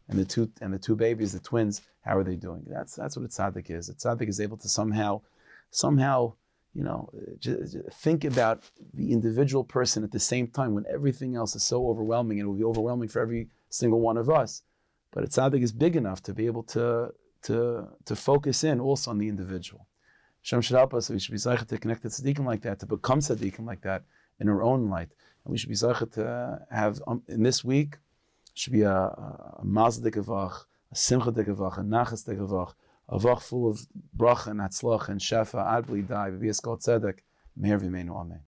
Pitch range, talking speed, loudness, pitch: 100-125 Hz, 205 wpm, -28 LUFS, 115 Hz